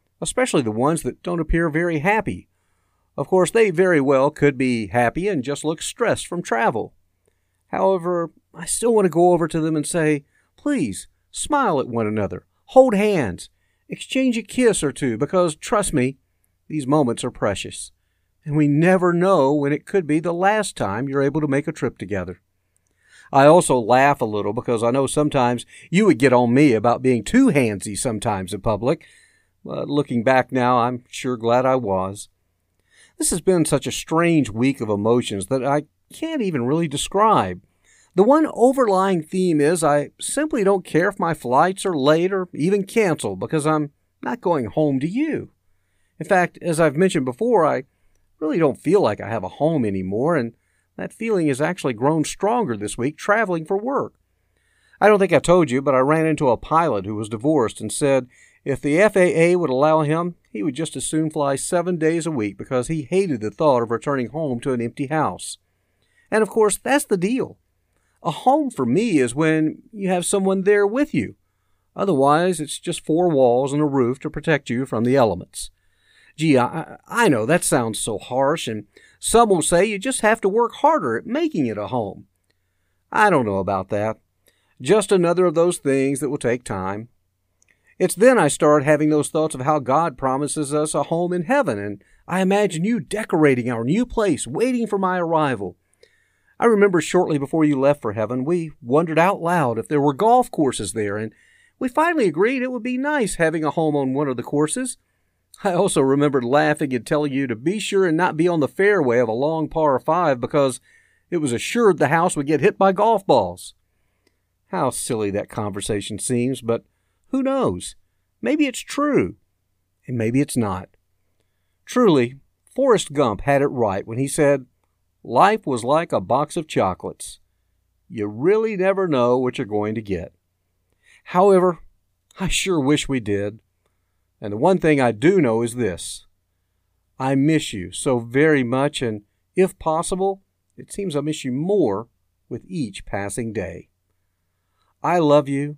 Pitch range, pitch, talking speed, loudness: 110-180 Hz, 145 Hz, 185 wpm, -20 LUFS